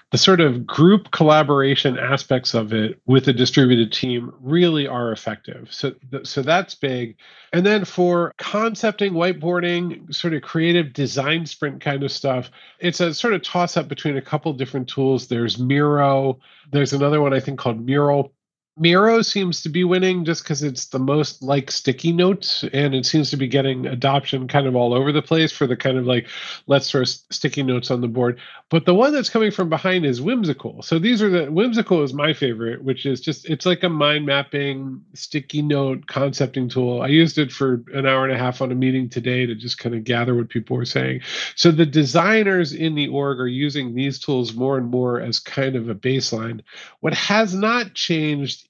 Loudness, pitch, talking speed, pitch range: -19 LUFS, 140 Hz, 200 wpm, 130-170 Hz